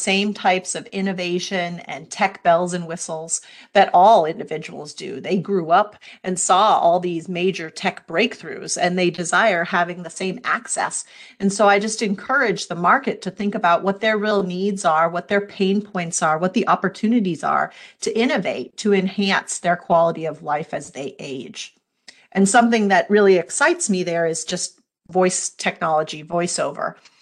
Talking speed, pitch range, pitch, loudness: 170 wpm, 175-200 Hz, 185 Hz, -20 LUFS